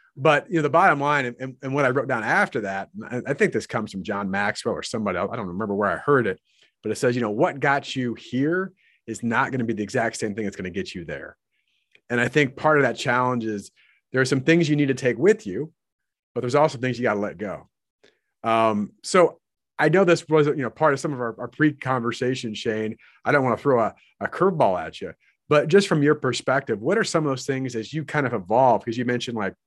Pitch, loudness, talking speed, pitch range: 130 Hz, -23 LUFS, 260 wpm, 115-150 Hz